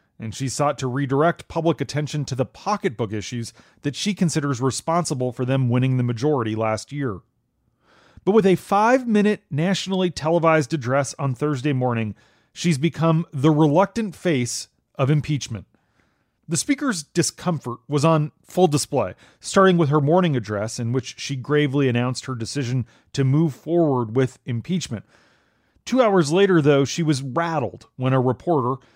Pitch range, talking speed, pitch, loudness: 125-170 Hz, 155 wpm, 145 Hz, -22 LUFS